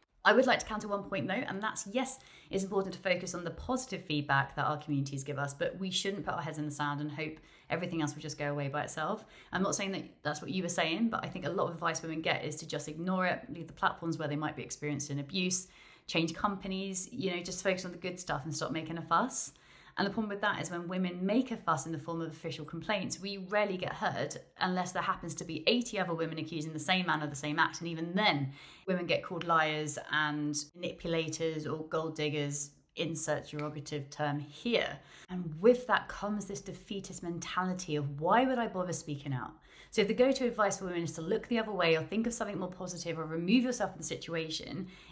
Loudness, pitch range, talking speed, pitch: -34 LUFS, 150-190 Hz, 240 wpm, 170 Hz